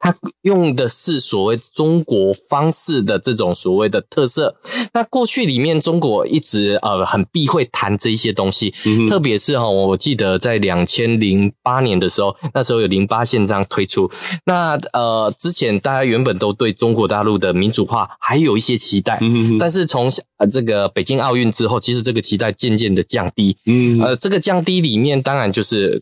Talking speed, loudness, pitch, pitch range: 280 characters per minute, -16 LUFS, 115 Hz, 105-145 Hz